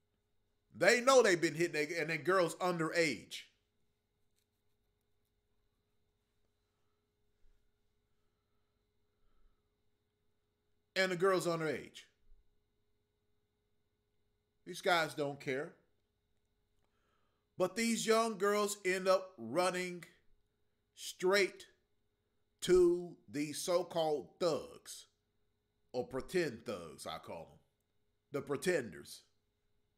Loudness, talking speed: -34 LUFS, 80 wpm